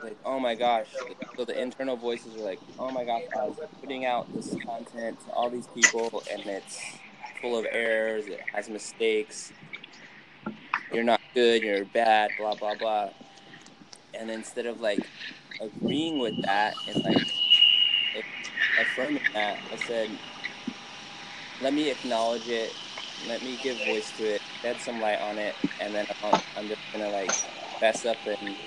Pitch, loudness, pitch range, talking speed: 115 Hz, -28 LUFS, 105-125 Hz, 165 wpm